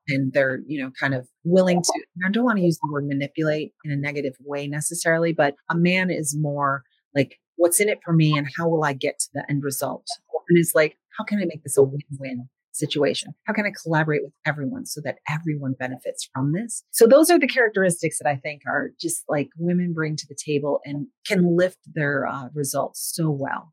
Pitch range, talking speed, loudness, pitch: 140-175 Hz, 225 wpm, -23 LUFS, 150 Hz